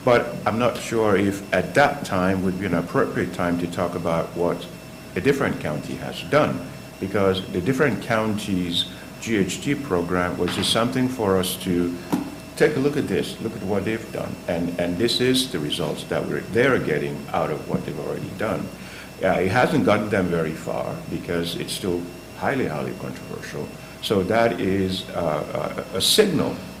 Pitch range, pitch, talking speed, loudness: 85-100 Hz, 90 Hz, 180 wpm, -23 LUFS